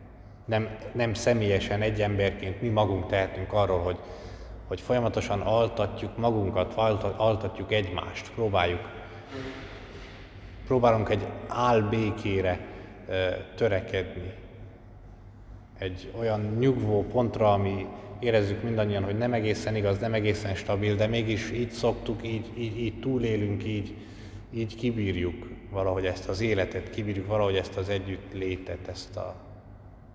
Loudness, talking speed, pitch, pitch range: -28 LUFS, 115 wpm, 105 Hz, 95-110 Hz